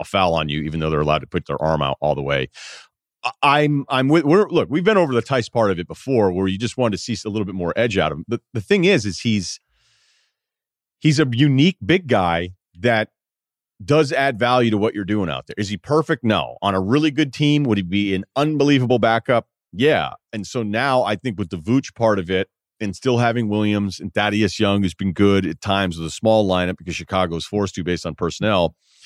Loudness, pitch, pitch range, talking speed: -19 LUFS, 105 Hz, 95-130 Hz, 240 wpm